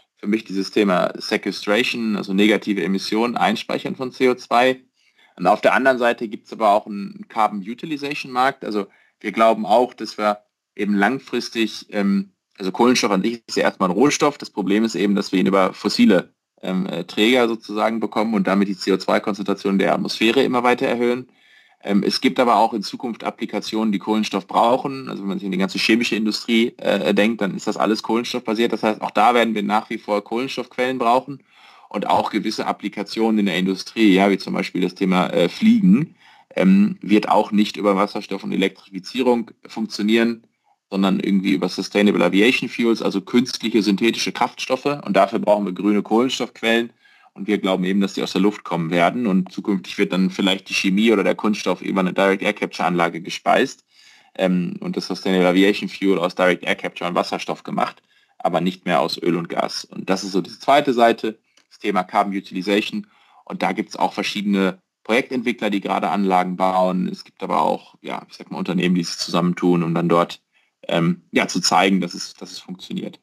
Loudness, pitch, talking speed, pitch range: -20 LUFS, 105 Hz, 190 wpm, 95-115 Hz